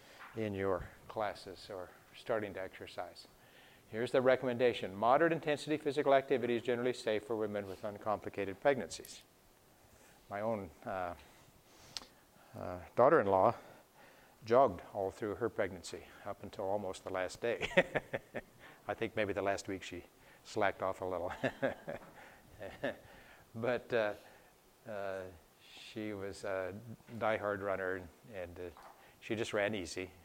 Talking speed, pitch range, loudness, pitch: 125 wpm, 95-115 Hz, -36 LUFS, 105 Hz